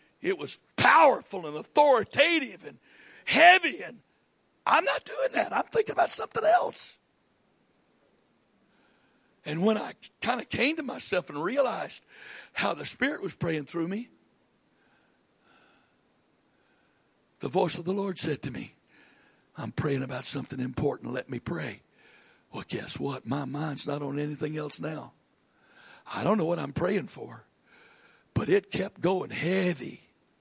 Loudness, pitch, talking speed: -27 LUFS, 175 Hz, 140 wpm